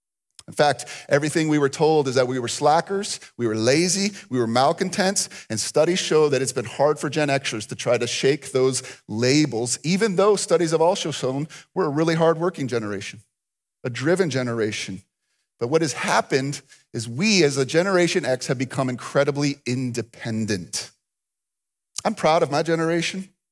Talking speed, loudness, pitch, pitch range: 170 wpm, -22 LUFS, 145 Hz, 125-165 Hz